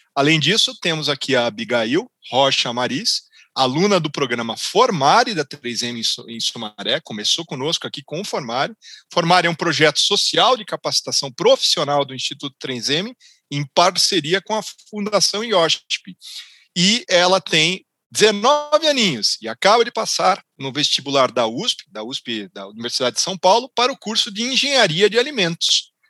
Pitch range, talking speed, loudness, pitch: 130-205 Hz, 150 wpm, -18 LUFS, 160 Hz